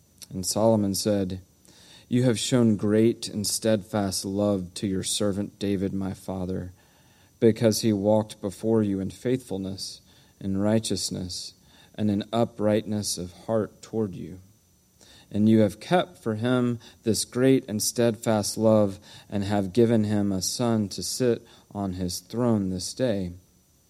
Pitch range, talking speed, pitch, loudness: 95-110 Hz, 140 wpm, 105 Hz, -26 LUFS